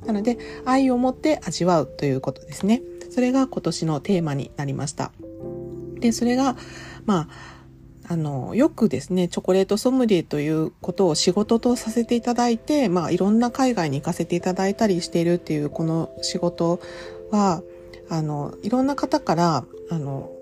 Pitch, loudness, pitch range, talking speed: 175 Hz, -23 LUFS, 150-225 Hz, 345 characters per minute